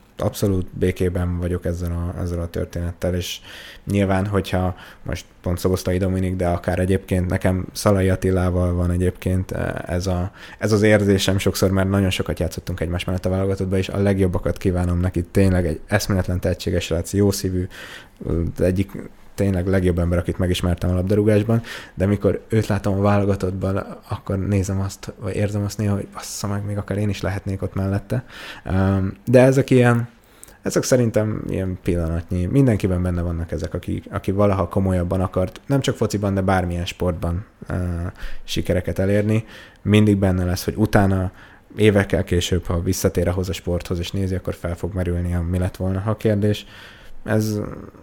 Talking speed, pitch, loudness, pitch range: 165 wpm, 95 Hz, -21 LUFS, 90-100 Hz